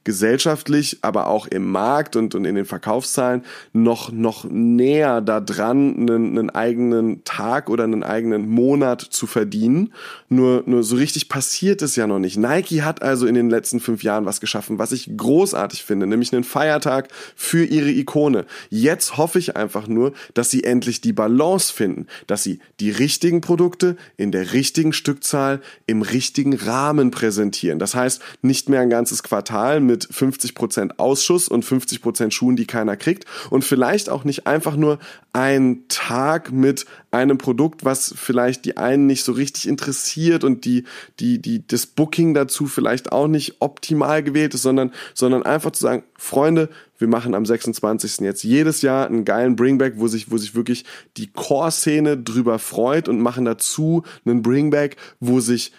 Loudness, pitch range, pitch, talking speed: -19 LUFS, 115-150 Hz, 130 Hz, 170 wpm